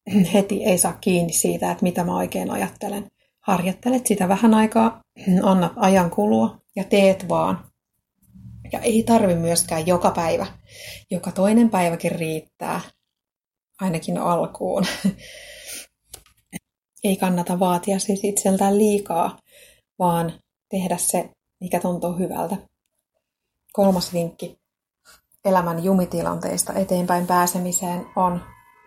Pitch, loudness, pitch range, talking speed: 185 Hz, -21 LUFS, 175-200 Hz, 105 wpm